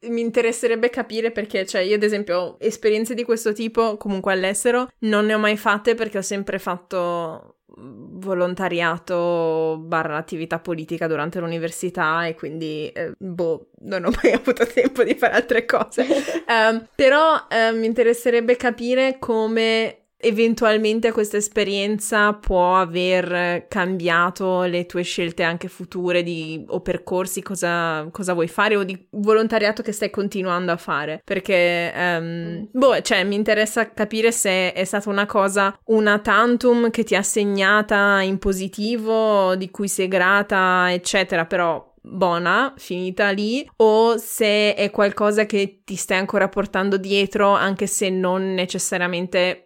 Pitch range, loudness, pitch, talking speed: 180-220 Hz, -20 LUFS, 200 Hz, 145 wpm